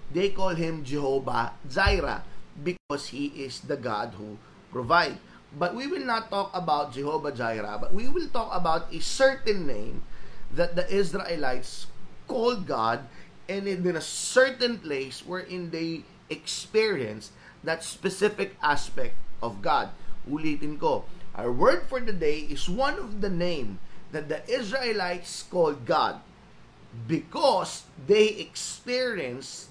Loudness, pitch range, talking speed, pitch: -28 LUFS, 145-210 Hz, 135 wpm, 175 Hz